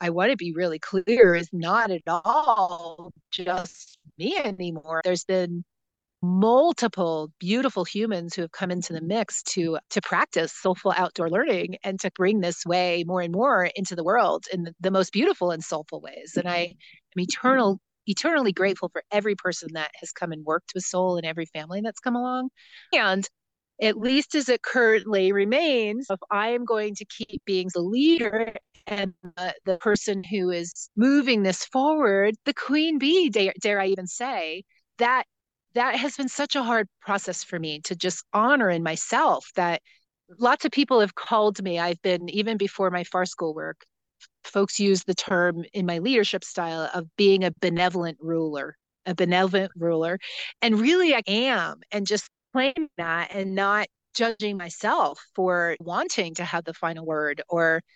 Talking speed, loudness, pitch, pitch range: 175 wpm, -24 LUFS, 190 Hz, 175-225 Hz